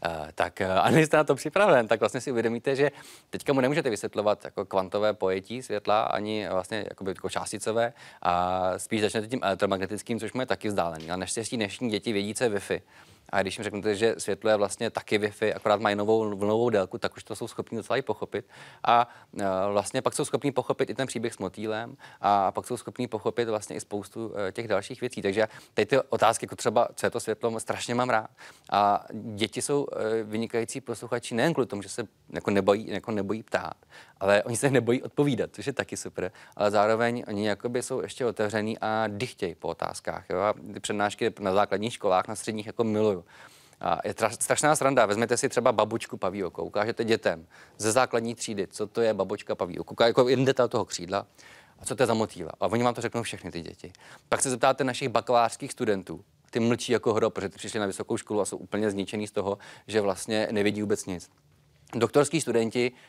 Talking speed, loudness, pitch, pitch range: 205 wpm, -28 LUFS, 110 Hz, 100-120 Hz